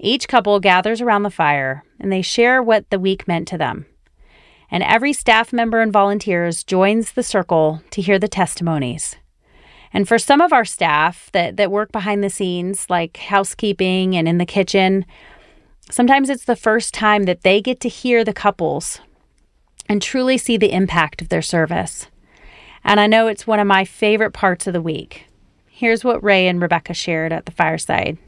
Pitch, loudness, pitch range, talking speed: 200 Hz, -17 LUFS, 180-225 Hz, 185 wpm